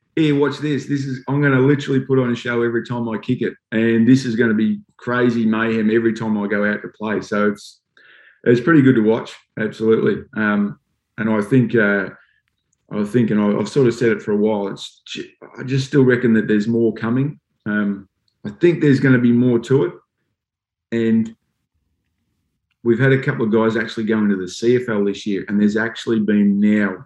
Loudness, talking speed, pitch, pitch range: -18 LUFS, 210 wpm, 115 Hz, 105-125 Hz